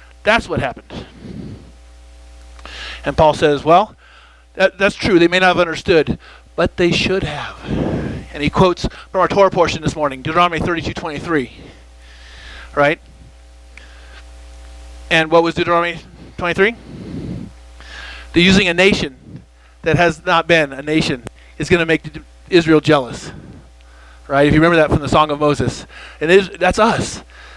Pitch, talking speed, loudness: 150 Hz, 150 wpm, -15 LUFS